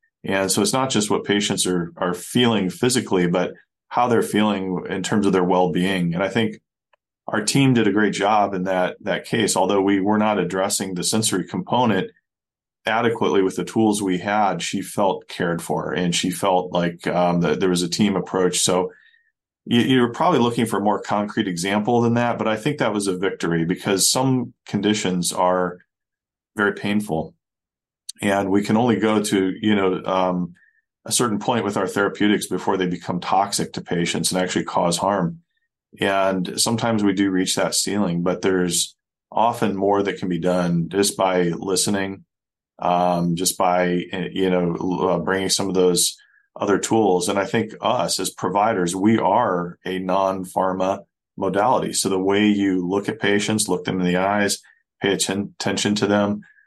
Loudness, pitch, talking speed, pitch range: -21 LUFS, 95 Hz, 180 wpm, 90-105 Hz